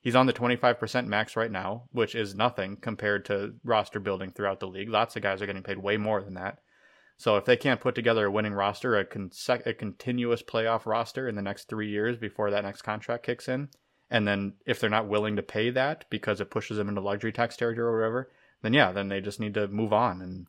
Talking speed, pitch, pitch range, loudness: 240 wpm, 110 Hz, 100-120 Hz, -29 LUFS